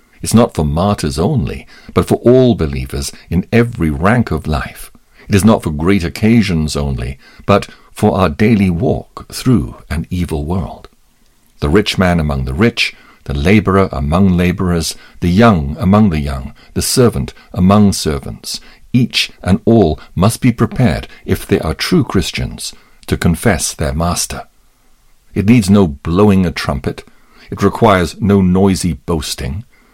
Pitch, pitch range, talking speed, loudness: 90 Hz, 80-105 Hz, 150 wpm, -14 LUFS